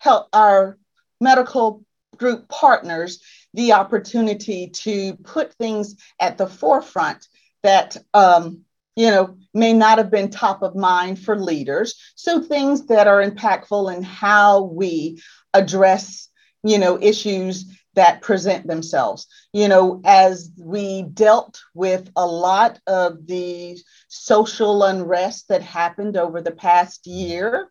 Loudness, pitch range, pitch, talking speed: -17 LUFS, 180-215 Hz, 195 Hz, 130 wpm